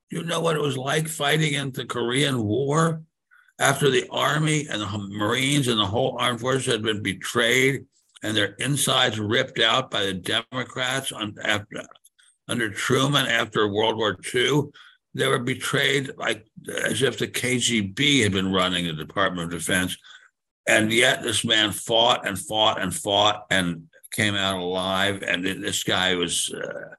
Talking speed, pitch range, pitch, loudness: 165 wpm, 100-135 Hz, 120 Hz, -22 LUFS